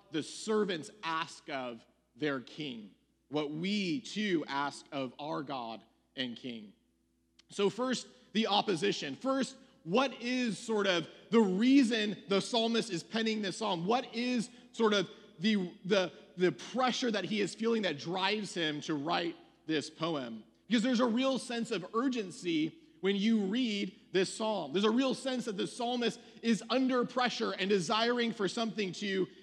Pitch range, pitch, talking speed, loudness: 170-235 Hz, 210 Hz, 160 wpm, -33 LUFS